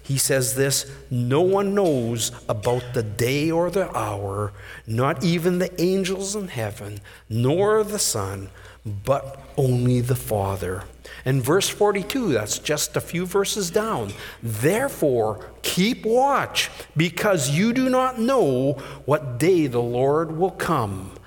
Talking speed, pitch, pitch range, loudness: 135 wpm, 135 Hz, 115-190 Hz, -22 LUFS